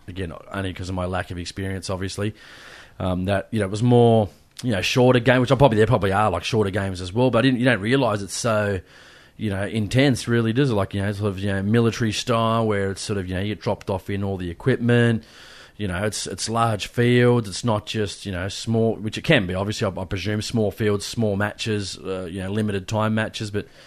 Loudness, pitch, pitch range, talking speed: -22 LUFS, 105 Hz, 95-115 Hz, 245 wpm